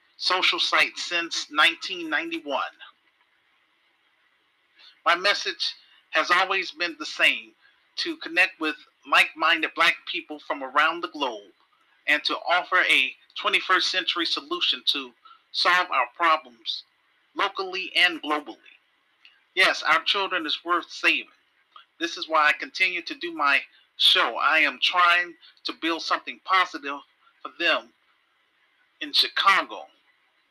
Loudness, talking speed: -23 LUFS, 120 wpm